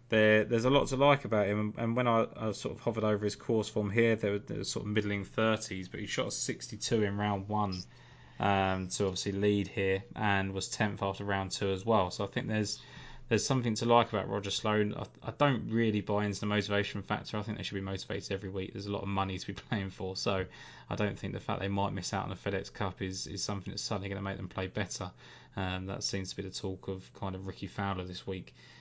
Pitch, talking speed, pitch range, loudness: 100 Hz, 255 wpm, 95-110 Hz, -33 LUFS